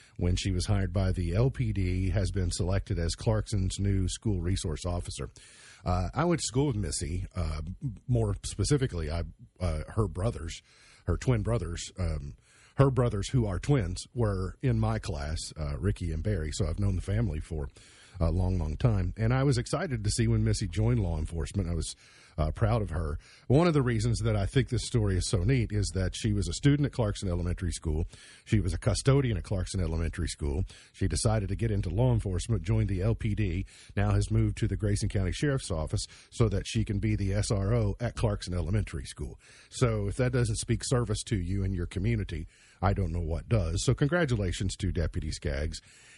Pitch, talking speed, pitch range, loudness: 100 Hz, 200 wpm, 90-115 Hz, -30 LUFS